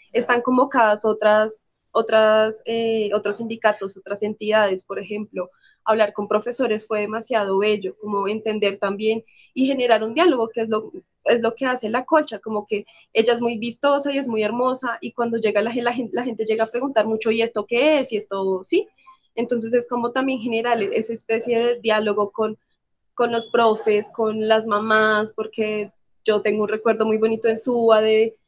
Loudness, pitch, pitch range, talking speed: -21 LUFS, 220 Hz, 215-235 Hz, 185 wpm